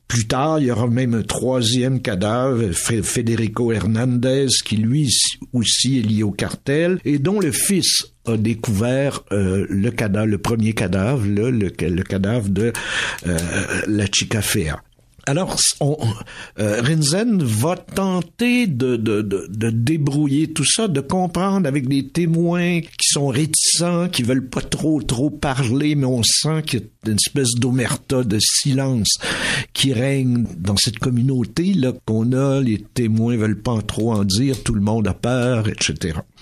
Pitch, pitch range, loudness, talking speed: 125 Hz, 110-145 Hz, -19 LUFS, 160 wpm